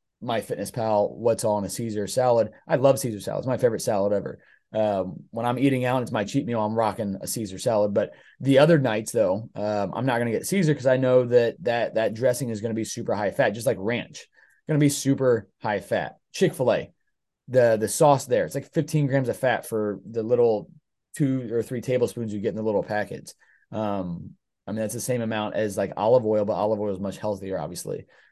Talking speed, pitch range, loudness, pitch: 220 wpm, 105-130 Hz, -24 LUFS, 115 Hz